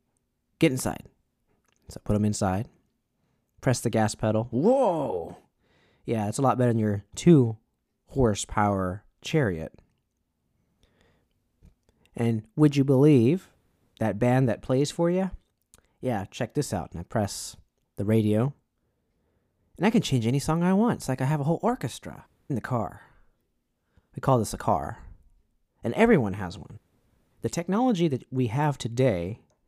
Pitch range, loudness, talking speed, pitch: 105-140 Hz, -26 LUFS, 150 wpm, 120 Hz